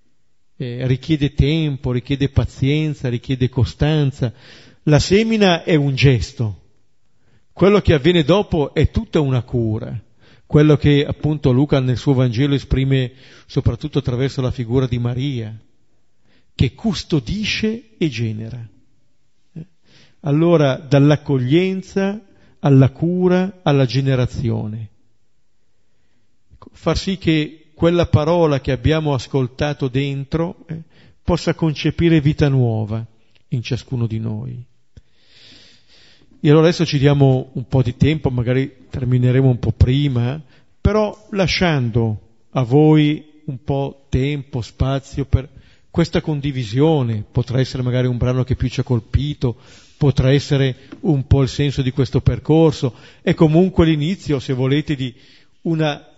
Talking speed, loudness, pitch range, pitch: 120 wpm, -18 LUFS, 125-155 Hz, 135 Hz